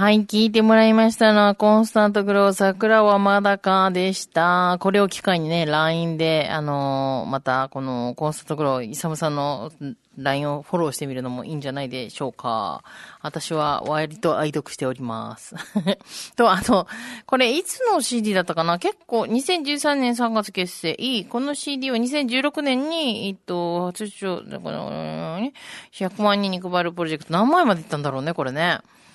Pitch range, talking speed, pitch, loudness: 155-225 Hz, 335 characters per minute, 185 Hz, -21 LUFS